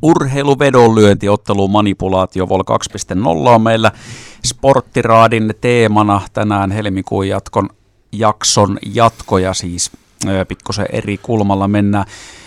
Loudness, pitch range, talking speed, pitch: -13 LUFS, 95-115 Hz, 85 wpm, 105 Hz